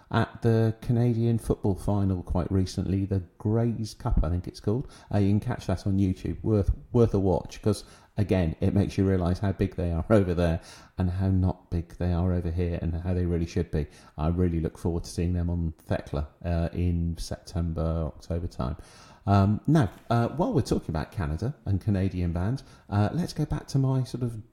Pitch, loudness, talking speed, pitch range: 95 Hz, -28 LUFS, 205 wpm, 85-110 Hz